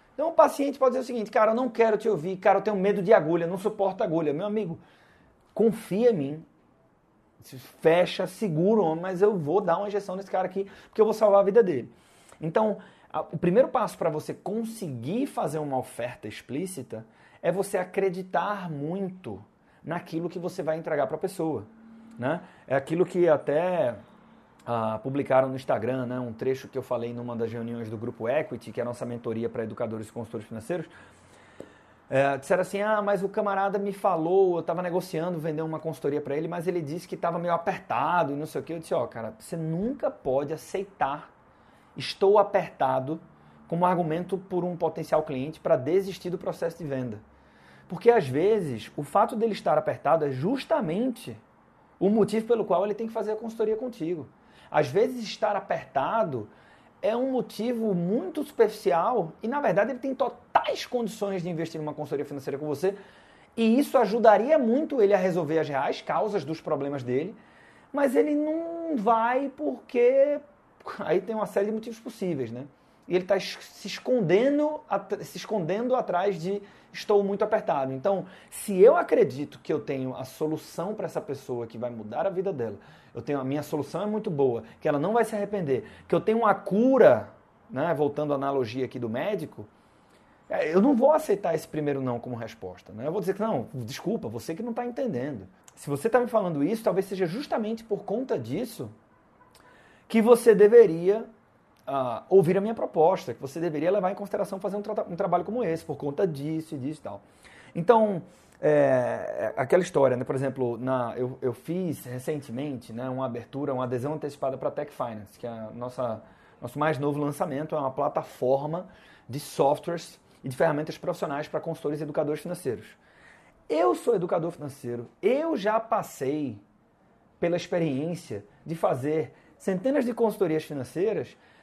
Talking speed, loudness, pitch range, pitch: 180 wpm, -27 LUFS, 140-210 Hz, 175 Hz